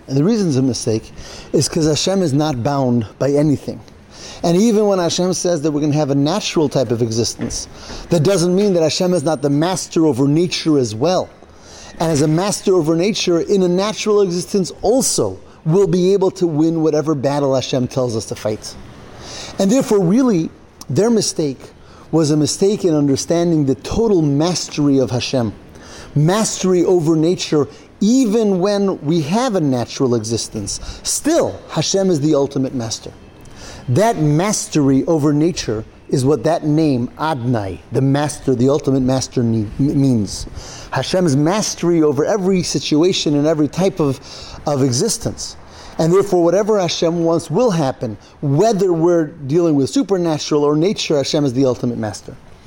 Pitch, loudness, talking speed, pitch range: 155 Hz, -16 LUFS, 160 wpm, 135-180 Hz